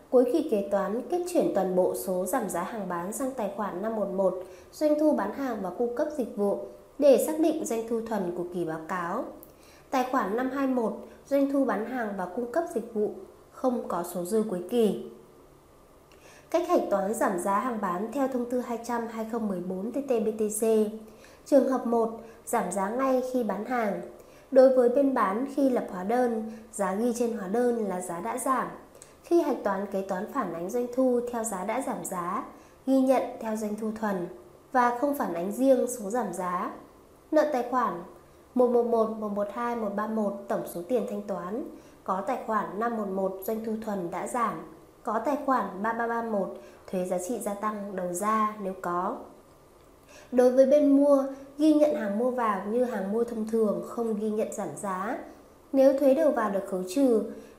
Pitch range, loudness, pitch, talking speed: 200-255 Hz, -28 LUFS, 230 Hz, 185 wpm